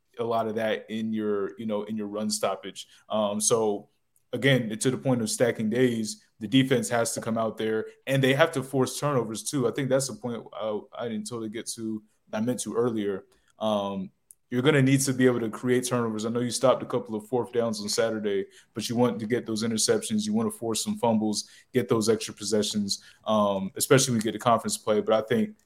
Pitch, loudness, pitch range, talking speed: 115 Hz, -27 LUFS, 110-125 Hz, 235 wpm